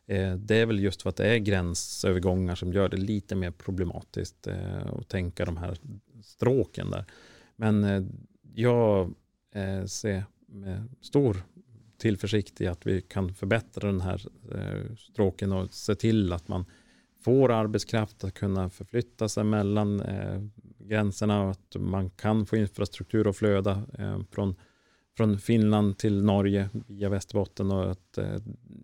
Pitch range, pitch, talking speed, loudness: 95-110 Hz, 100 Hz, 135 wpm, -29 LUFS